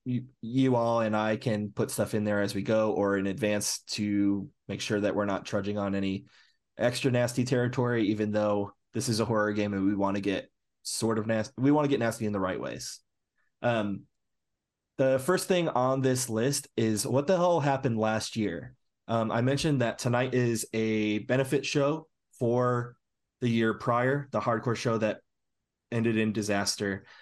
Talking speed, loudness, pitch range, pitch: 190 wpm, -29 LUFS, 105-125 Hz, 115 Hz